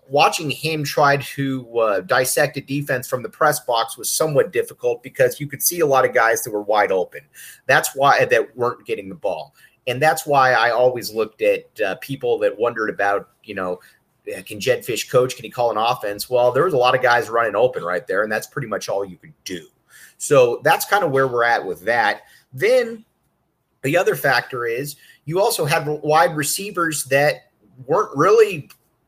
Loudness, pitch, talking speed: -19 LUFS, 170 Hz, 200 wpm